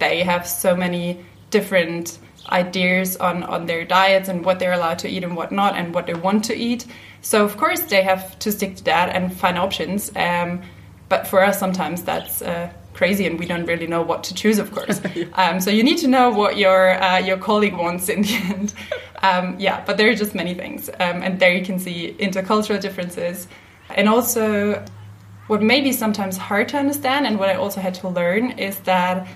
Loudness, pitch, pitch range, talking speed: -19 LUFS, 190 Hz, 180-205 Hz, 215 wpm